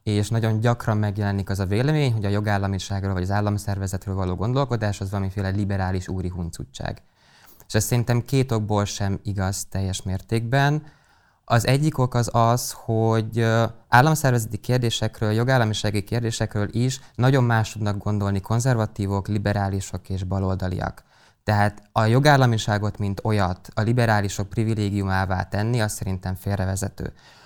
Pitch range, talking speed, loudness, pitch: 100-115 Hz, 130 wpm, -23 LUFS, 105 Hz